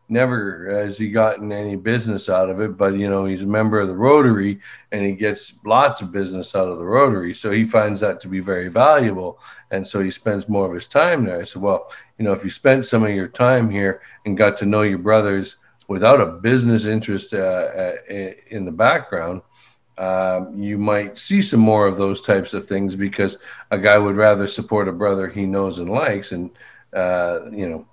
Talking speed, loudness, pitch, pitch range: 215 wpm, -19 LUFS, 100 Hz, 95-110 Hz